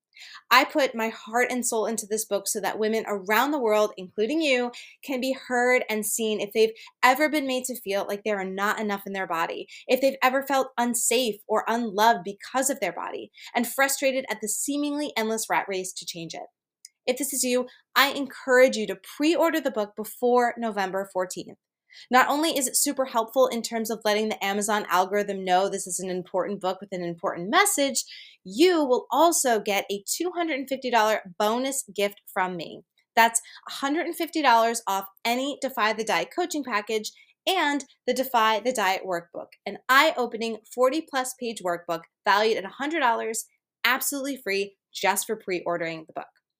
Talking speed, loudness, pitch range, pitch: 180 wpm, -25 LUFS, 200-265 Hz, 230 Hz